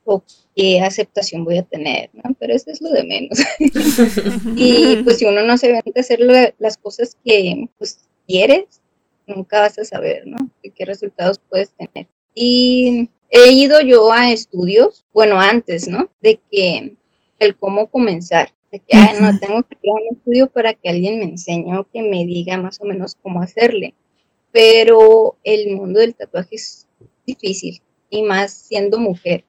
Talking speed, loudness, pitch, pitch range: 175 wpm, -14 LUFS, 215 Hz, 195-245 Hz